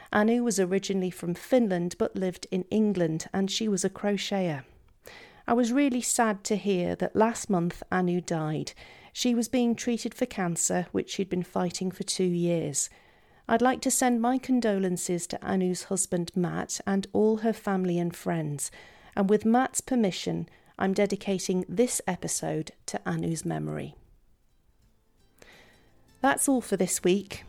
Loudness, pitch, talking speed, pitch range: -28 LUFS, 195 Hz, 155 wpm, 175-225 Hz